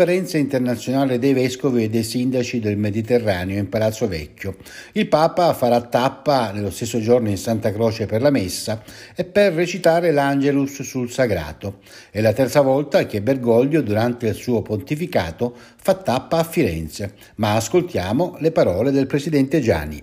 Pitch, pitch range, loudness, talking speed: 125 Hz, 110-140 Hz, -20 LUFS, 155 wpm